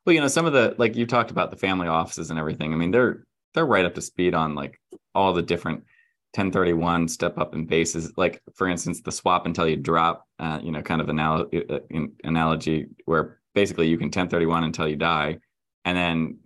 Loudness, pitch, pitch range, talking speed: -24 LUFS, 85 Hz, 80-90 Hz, 225 wpm